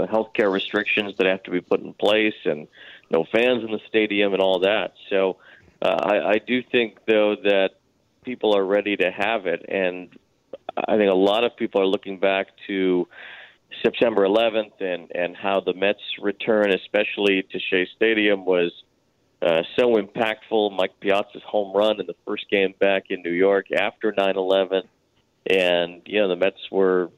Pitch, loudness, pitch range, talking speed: 100 Hz, -22 LUFS, 95-105 Hz, 175 wpm